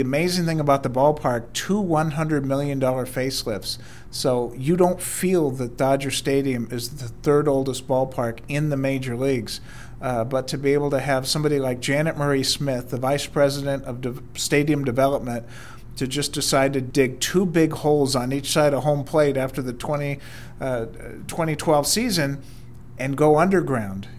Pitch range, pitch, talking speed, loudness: 125-145 Hz, 135 Hz, 165 wpm, -22 LUFS